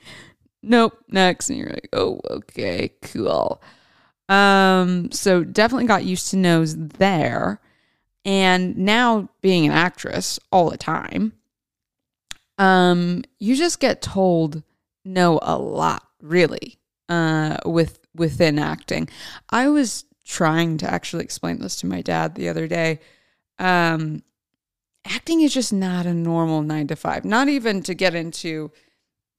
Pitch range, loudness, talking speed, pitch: 160-215 Hz, -20 LUFS, 135 wpm, 185 Hz